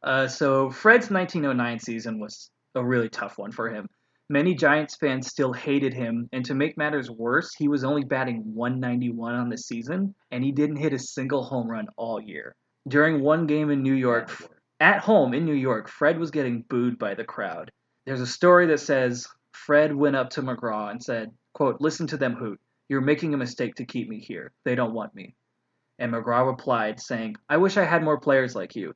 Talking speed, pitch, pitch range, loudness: 205 wpm, 135 Hz, 120-150 Hz, -24 LUFS